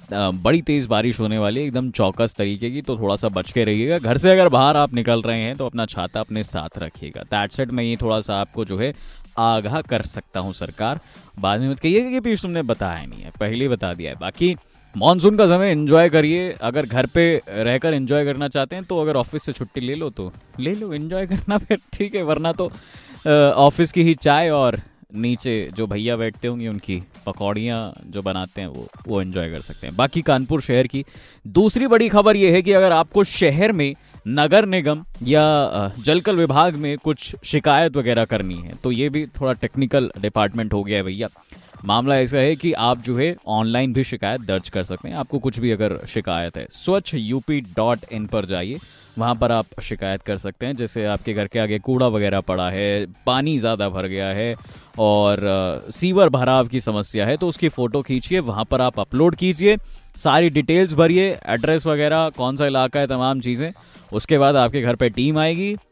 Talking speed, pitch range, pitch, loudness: 210 wpm, 105-155 Hz, 125 Hz, -20 LUFS